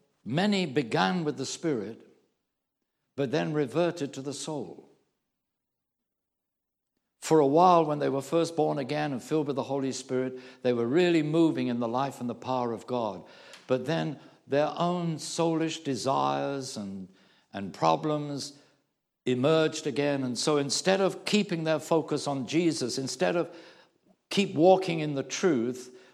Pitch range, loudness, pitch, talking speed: 130-160 Hz, -28 LUFS, 145 Hz, 150 wpm